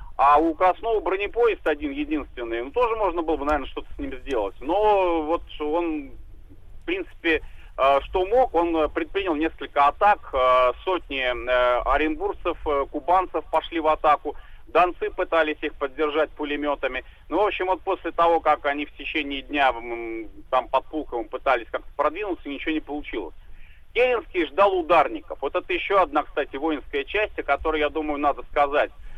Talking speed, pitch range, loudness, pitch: 150 wpm, 140-185 Hz, -24 LUFS, 155 Hz